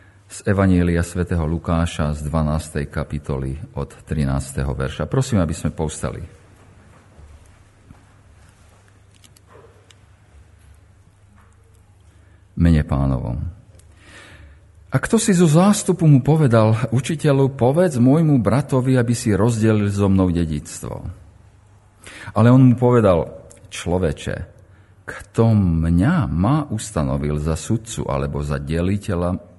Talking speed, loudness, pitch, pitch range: 95 wpm, -19 LUFS, 95 Hz, 85-110 Hz